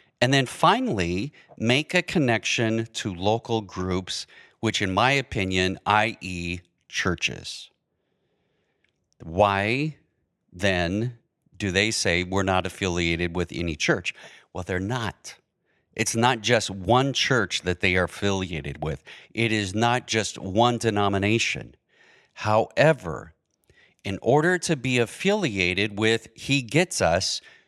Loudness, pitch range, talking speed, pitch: -24 LUFS, 95-120 Hz, 120 wpm, 105 Hz